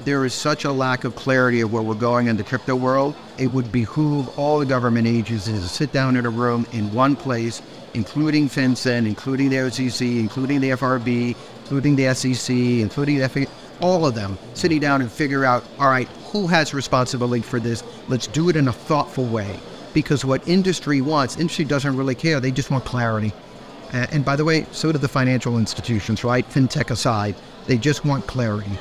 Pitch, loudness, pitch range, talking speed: 130 Hz, -21 LUFS, 120-140 Hz, 200 wpm